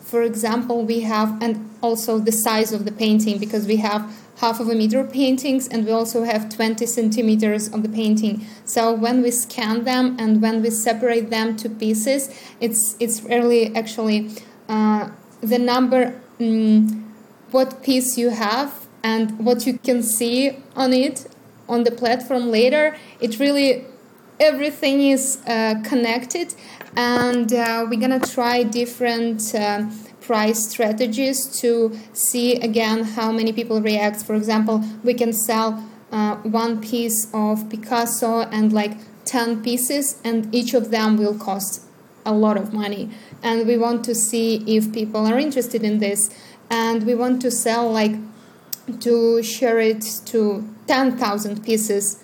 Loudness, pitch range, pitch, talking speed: -20 LUFS, 220-245 Hz, 230 Hz, 155 wpm